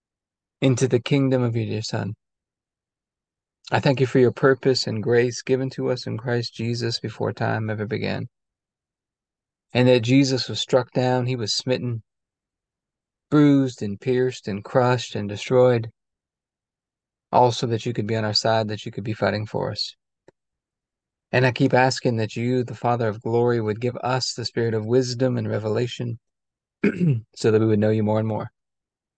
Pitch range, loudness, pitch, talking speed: 110-130 Hz, -22 LUFS, 120 Hz, 175 wpm